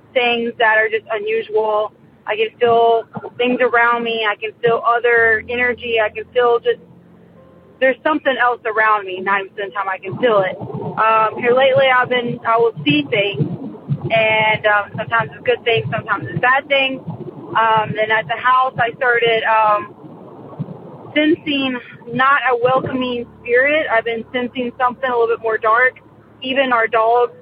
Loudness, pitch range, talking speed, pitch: -16 LUFS, 220-250 Hz, 170 wpm, 235 Hz